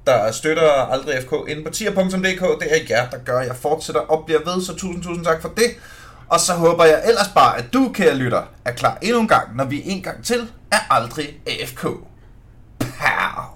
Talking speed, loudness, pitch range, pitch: 215 wpm, -19 LUFS, 150-190 Hz, 165 Hz